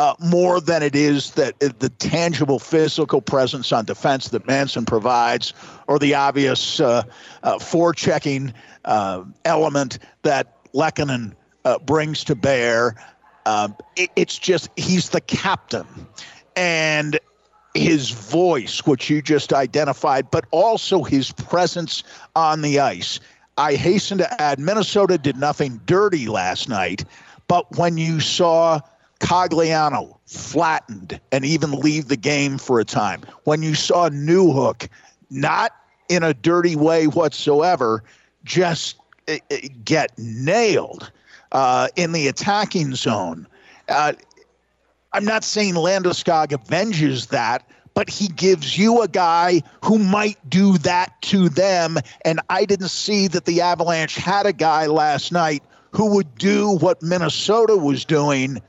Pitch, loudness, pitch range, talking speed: 155 Hz, -19 LUFS, 140-180 Hz, 135 wpm